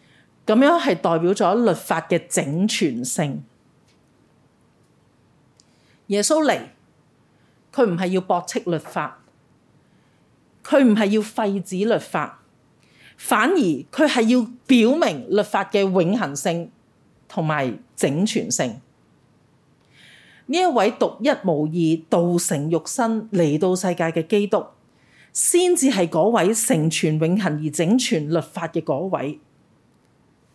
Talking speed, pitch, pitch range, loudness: 165 characters per minute, 200 Hz, 170-235 Hz, -20 LUFS